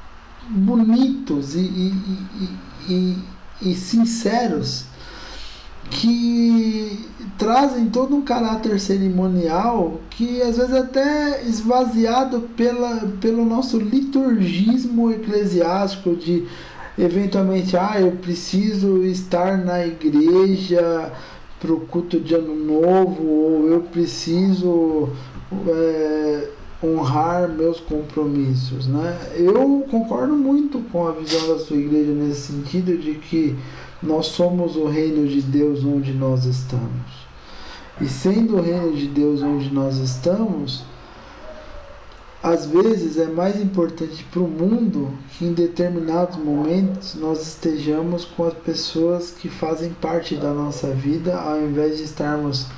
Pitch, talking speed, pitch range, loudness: 175 Hz, 115 wpm, 155-205 Hz, -20 LUFS